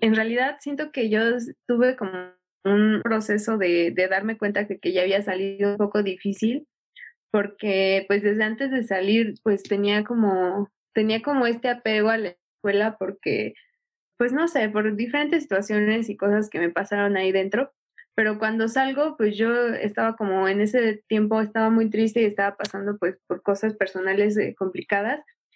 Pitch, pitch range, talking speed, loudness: 210 Hz, 200-230 Hz, 170 wpm, -23 LUFS